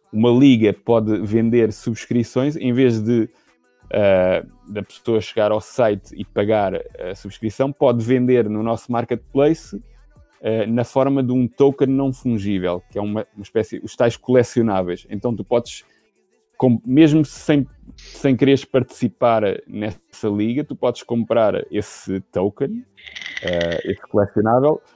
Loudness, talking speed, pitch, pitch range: -19 LUFS, 140 wpm, 120 Hz, 110-135 Hz